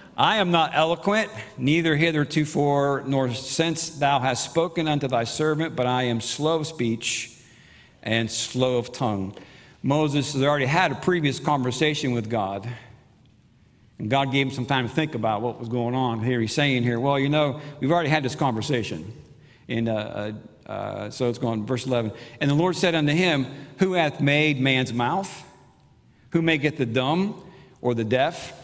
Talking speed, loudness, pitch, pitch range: 175 wpm, -24 LUFS, 135 Hz, 120-155 Hz